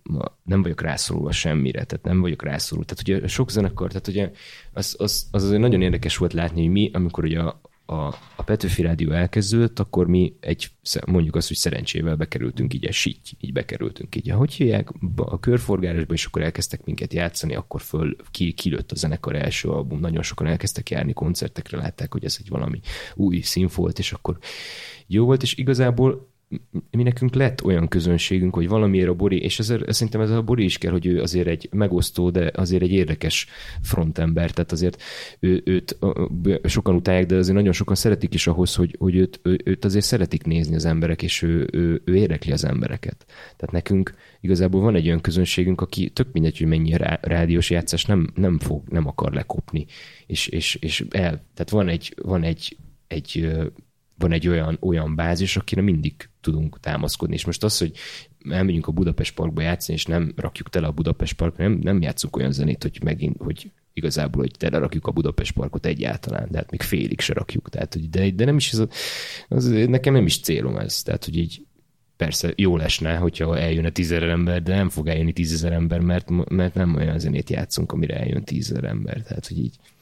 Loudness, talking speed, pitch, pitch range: -22 LUFS, 195 wpm, 90 Hz, 85-100 Hz